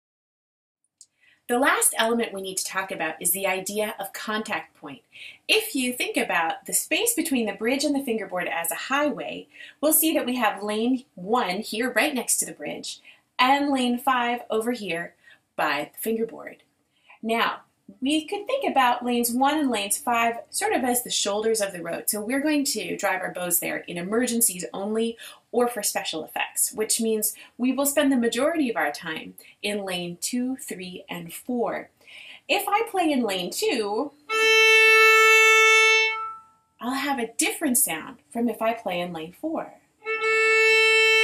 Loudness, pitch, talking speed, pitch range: -22 LUFS, 245 Hz, 170 wpm, 210-300 Hz